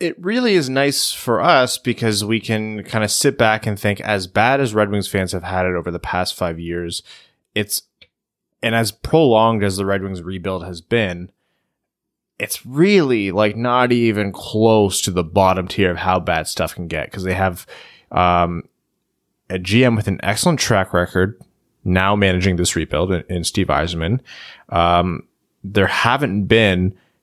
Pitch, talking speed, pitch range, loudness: 100 Hz, 170 wpm, 90-115 Hz, -18 LUFS